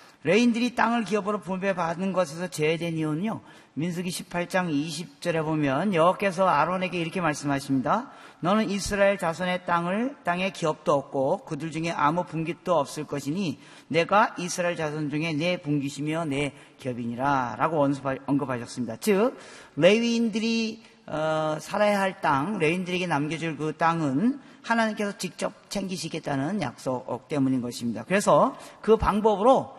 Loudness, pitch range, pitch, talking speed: -26 LUFS, 145-200 Hz, 170 Hz, 330 characters per minute